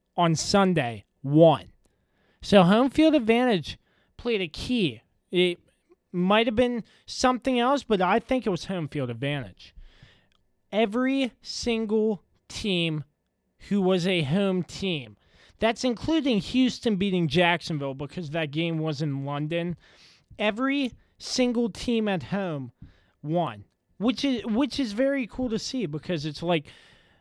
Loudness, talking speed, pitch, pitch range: -25 LUFS, 130 wpm, 185 Hz, 150-235 Hz